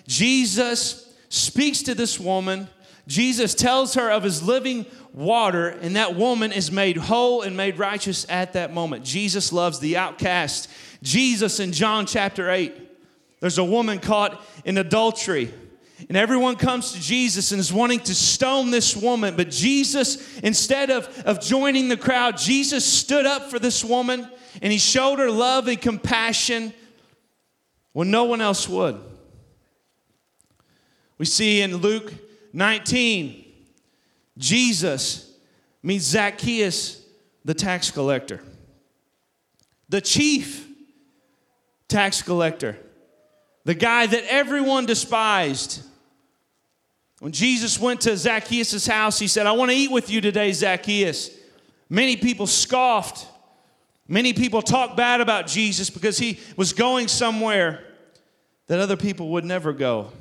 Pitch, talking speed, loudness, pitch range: 215 Hz, 135 wpm, -21 LUFS, 190-245 Hz